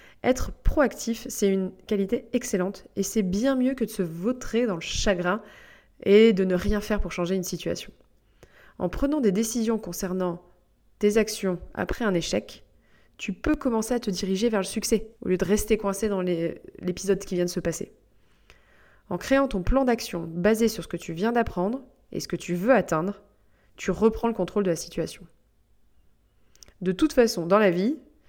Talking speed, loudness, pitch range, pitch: 190 wpm, -26 LUFS, 175-225 Hz, 200 Hz